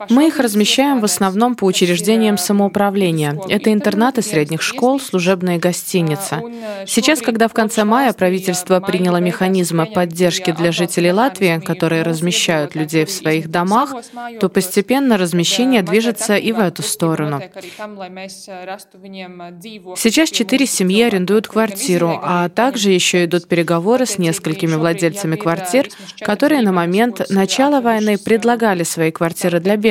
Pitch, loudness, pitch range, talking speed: 190 Hz, -15 LUFS, 175-225 Hz, 130 wpm